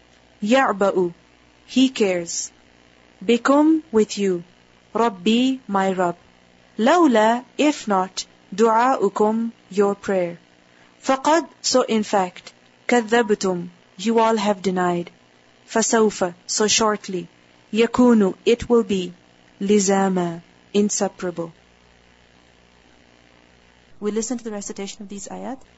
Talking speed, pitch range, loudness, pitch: 95 wpm, 170-225 Hz, -20 LUFS, 200 Hz